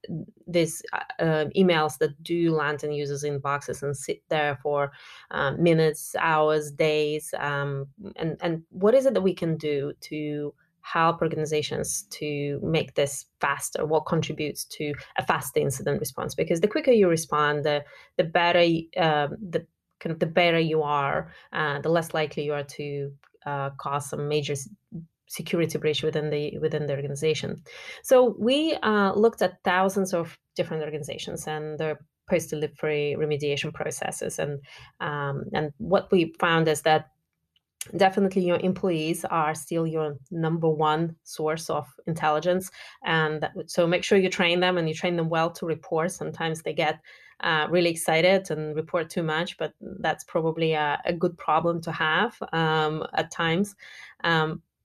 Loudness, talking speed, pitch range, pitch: -26 LUFS, 160 wpm, 150-175 Hz, 160 Hz